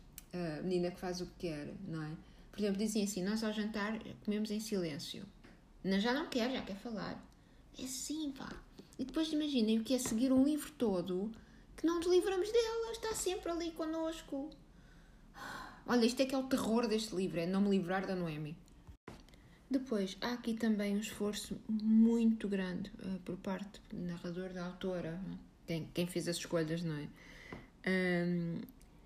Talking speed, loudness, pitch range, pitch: 175 wpm, -37 LUFS, 180-255 Hz, 210 Hz